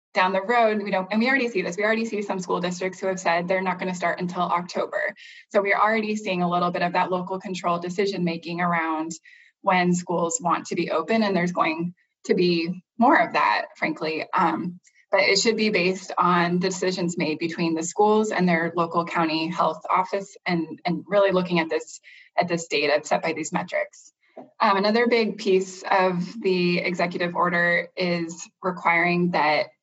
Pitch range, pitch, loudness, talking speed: 170-195 Hz, 180 Hz, -23 LUFS, 195 wpm